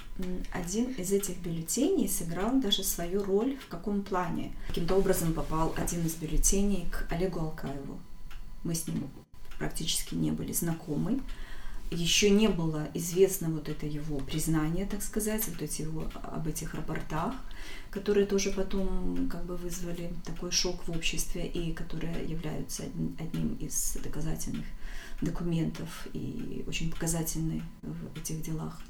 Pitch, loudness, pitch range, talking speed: 170 Hz, -32 LUFS, 155-190 Hz, 135 wpm